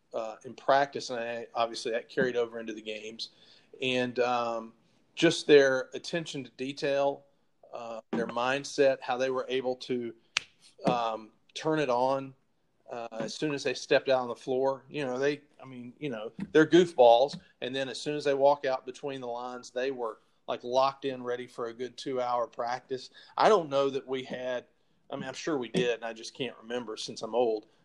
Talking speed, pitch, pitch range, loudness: 200 wpm, 130 Hz, 120-140 Hz, -30 LUFS